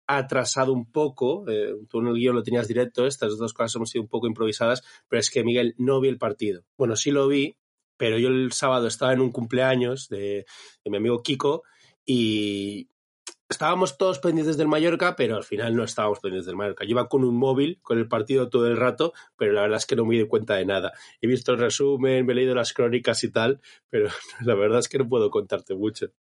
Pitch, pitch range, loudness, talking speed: 125 Hz, 115-140 Hz, -24 LUFS, 230 wpm